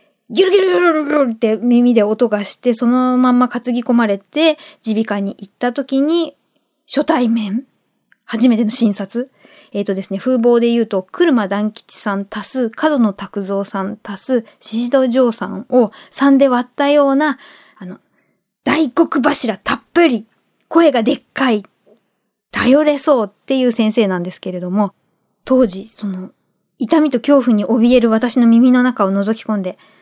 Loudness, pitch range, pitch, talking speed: -15 LUFS, 210-275 Hz, 240 Hz, 300 characters per minute